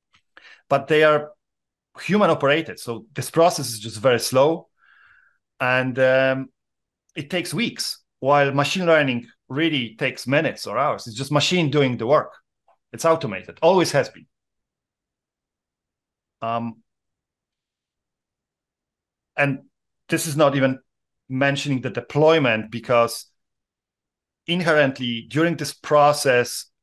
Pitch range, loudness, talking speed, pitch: 125-155 Hz, -21 LUFS, 110 wpm, 140 Hz